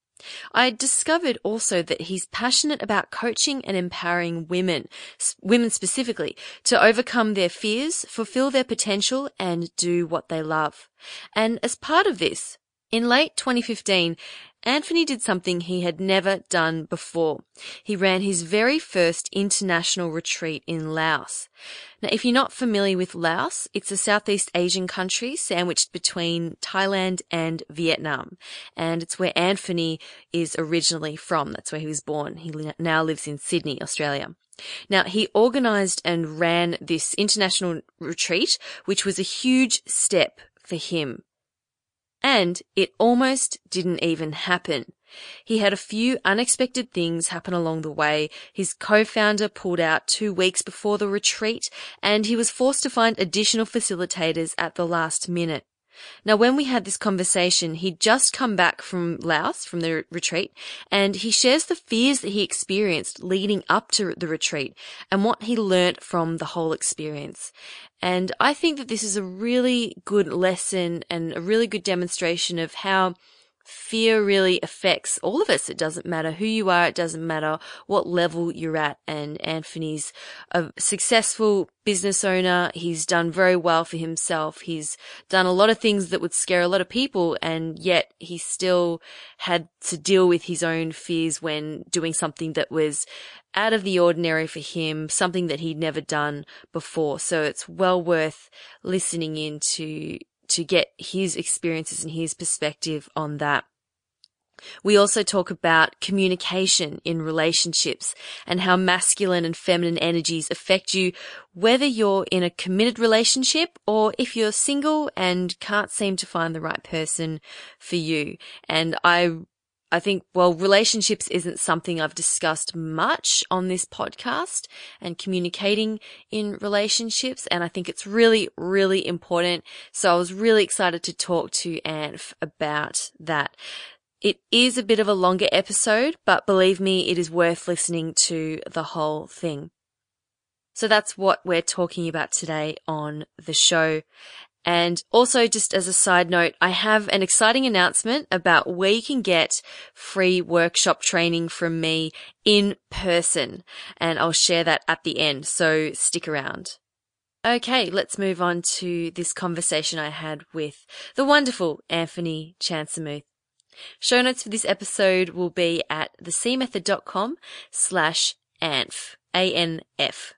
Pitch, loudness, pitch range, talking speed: 180 Hz, -22 LUFS, 165-210 Hz, 155 wpm